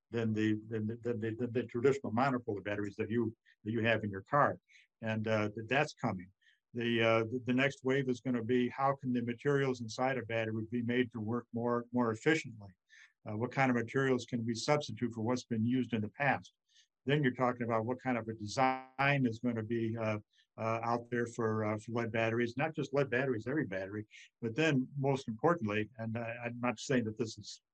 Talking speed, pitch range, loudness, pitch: 225 wpm, 110-130 Hz, -35 LUFS, 120 Hz